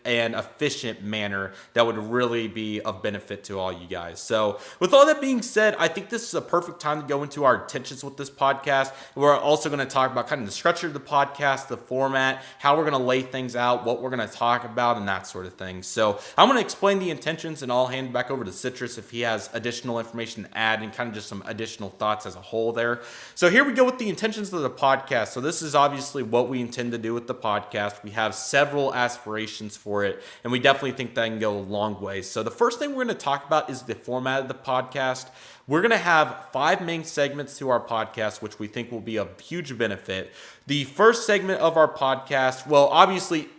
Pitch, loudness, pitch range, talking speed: 130 Hz, -24 LUFS, 110-145 Hz, 245 wpm